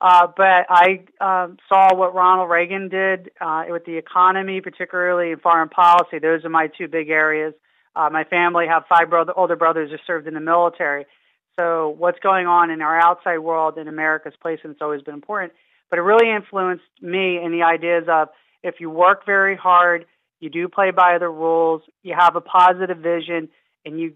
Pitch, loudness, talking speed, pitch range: 170 Hz, -18 LUFS, 195 wpm, 160-180 Hz